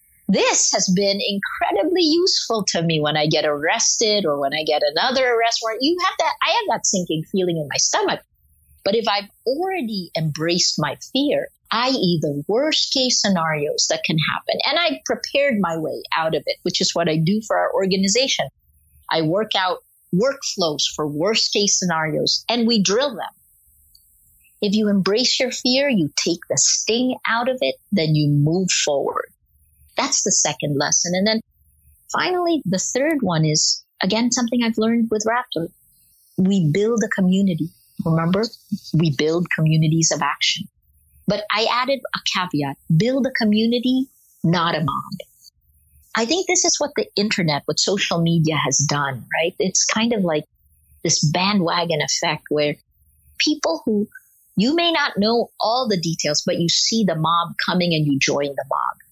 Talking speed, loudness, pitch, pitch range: 170 wpm, -19 LUFS, 185 Hz, 155-230 Hz